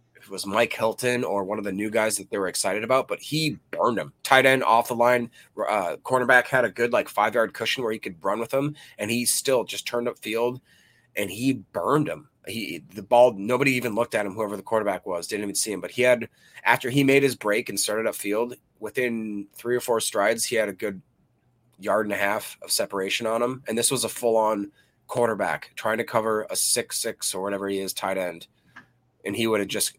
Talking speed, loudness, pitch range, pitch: 235 wpm, -24 LUFS, 105-125 Hz, 115 Hz